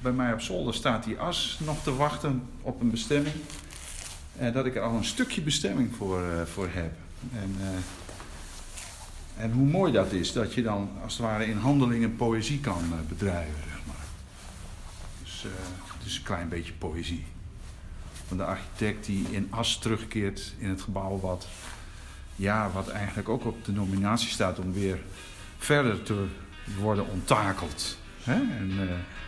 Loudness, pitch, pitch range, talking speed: -30 LUFS, 95 Hz, 90-115 Hz, 160 wpm